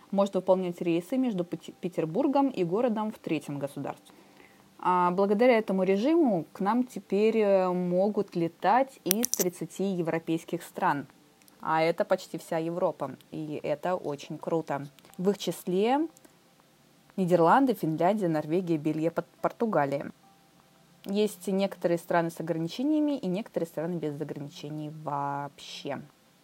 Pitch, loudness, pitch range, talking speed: 180 Hz, -29 LUFS, 165-200 Hz, 115 wpm